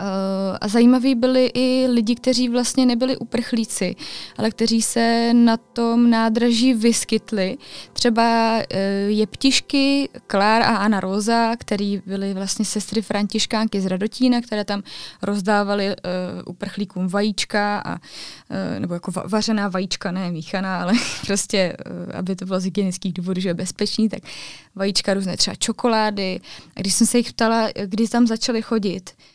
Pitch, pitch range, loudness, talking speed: 215 Hz, 195-235 Hz, -20 LUFS, 140 wpm